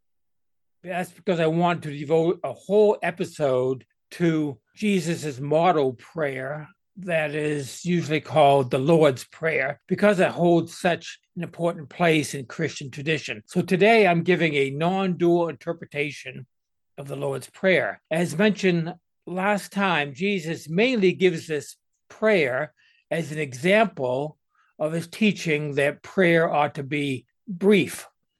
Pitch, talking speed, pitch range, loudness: 165 Hz, 135 wpm, 145-185 Hz, -23 LUFS